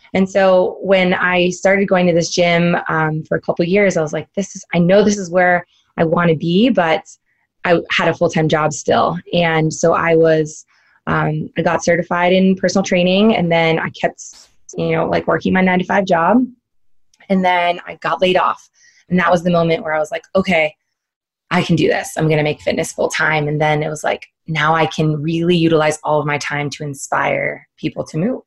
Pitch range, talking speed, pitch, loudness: 155-185 Hz, 215 wpm, 170 Hz, -16 LUFS